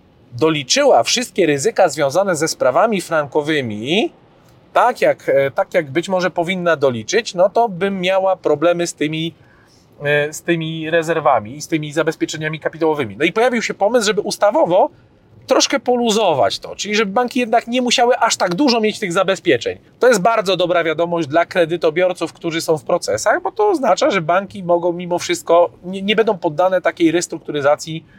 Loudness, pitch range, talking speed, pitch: -17 LUFS, 160-215 Hz, 165 wpm, 175 Hz